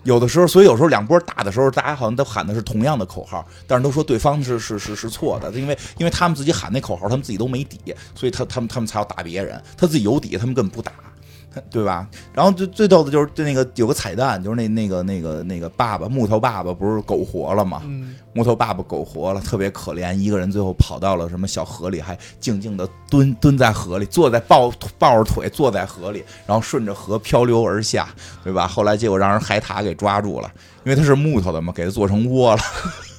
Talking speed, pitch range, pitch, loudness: 365 characters per minute, 95-130 Hz, 110 Hz, -19 LUFS